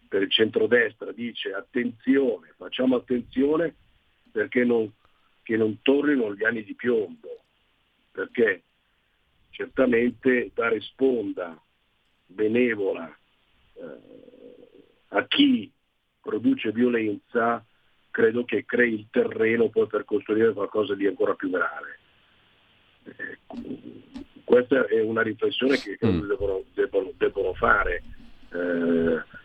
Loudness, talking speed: -25 LUFS, 100 wpm